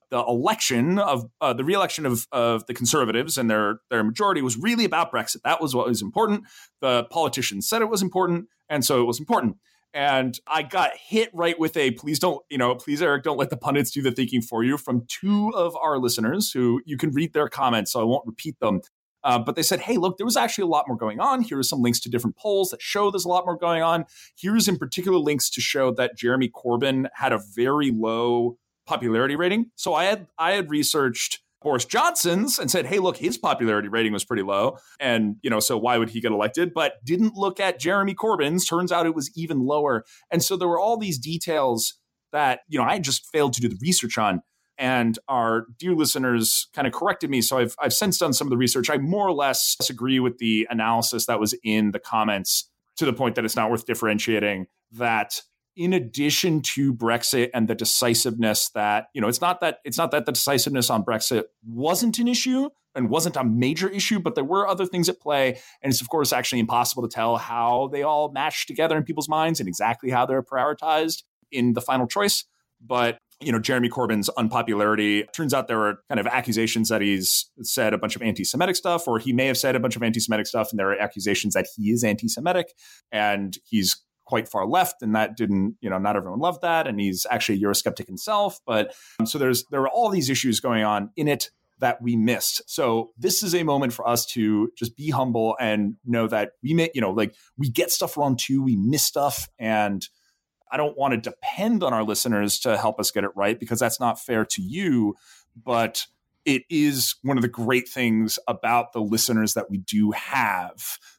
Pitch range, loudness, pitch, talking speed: 115-165 Hz, -23 LUFS, 130 Hz, 220 wpm